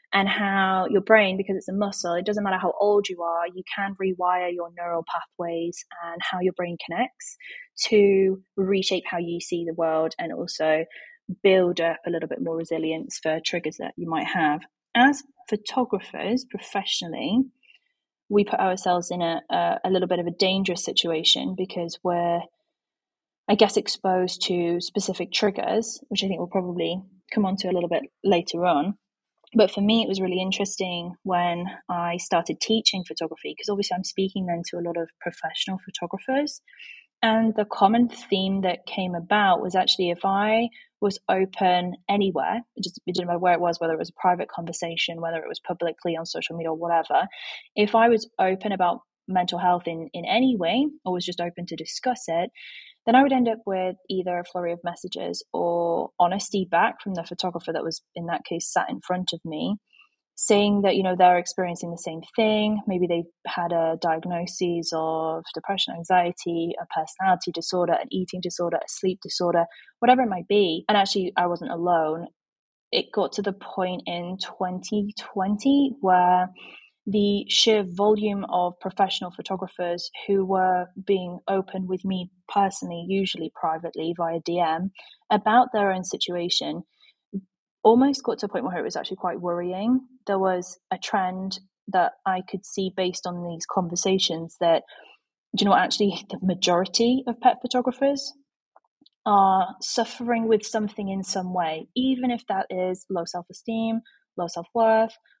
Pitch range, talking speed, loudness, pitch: 175-210 Hz, 175 wpm, -24 LUFS, 185 Hz